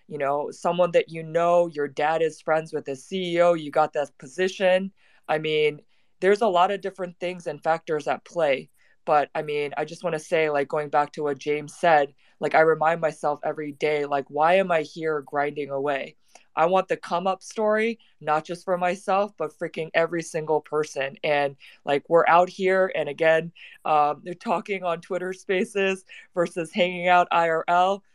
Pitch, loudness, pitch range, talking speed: 160 Hz, -24 LUFS, 150-180 Hz, 190 wpm